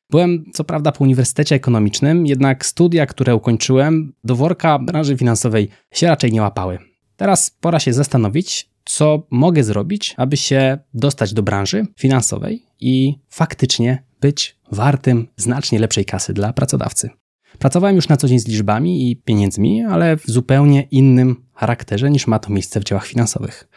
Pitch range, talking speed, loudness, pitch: 115-150 Hz, 155 wpm, -16 LUFS, 130 Hz